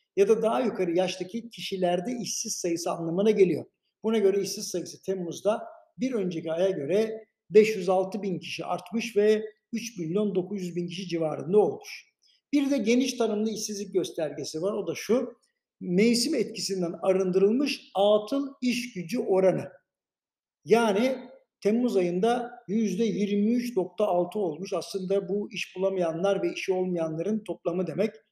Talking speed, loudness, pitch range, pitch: 130 wpm, -27 LUFS, 185-230 Hz, 205 Hz